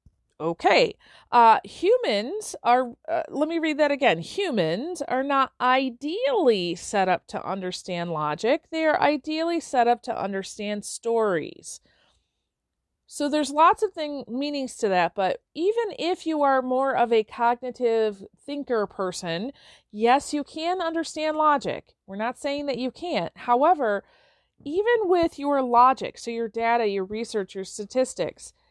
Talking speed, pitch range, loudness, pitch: 145 wpm, 220-310 Hz, -24 LUFS, 255 Hz